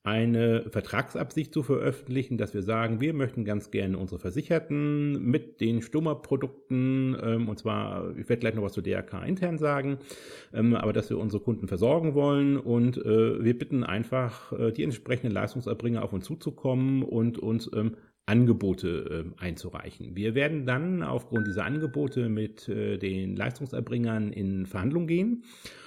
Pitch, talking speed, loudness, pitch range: 115 Hz, 140 wpm, -29 LUFS, 105-140 Hz